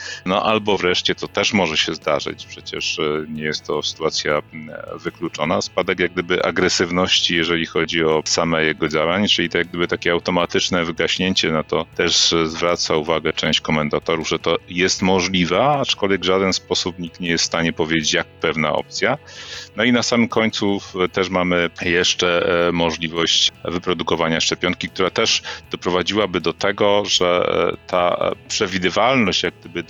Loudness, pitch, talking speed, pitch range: -18 LUFS, 90 Hz, 155 wpm, 85-95 Hz